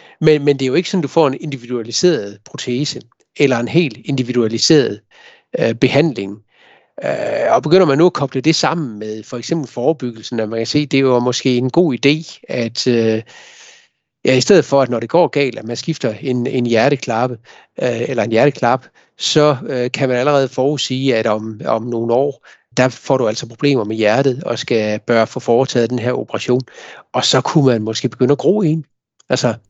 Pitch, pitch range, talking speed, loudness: 130 Hz, 120-145 Hz, 200 wpm, -16 LUFS